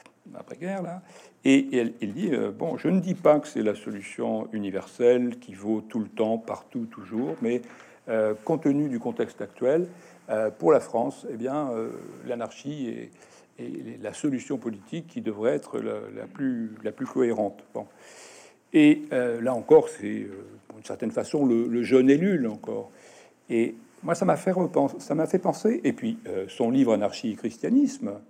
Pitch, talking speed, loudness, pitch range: 140 Hz, 185 wpm, -26 LUFS, 115-190 Hz